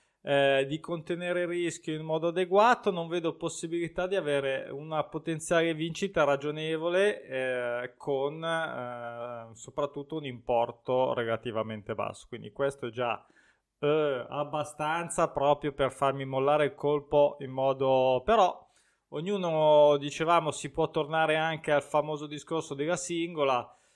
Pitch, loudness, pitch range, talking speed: 150 Hz, -29 LUFS, 135-165 Hz, 130 wpm